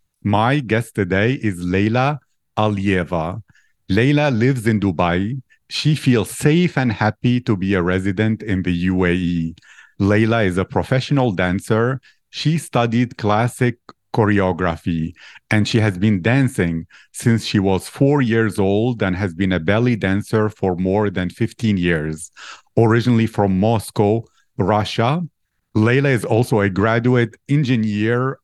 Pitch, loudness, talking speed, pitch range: 110 Hz, -18 LUFS, 135 wpm, 95-120 Hz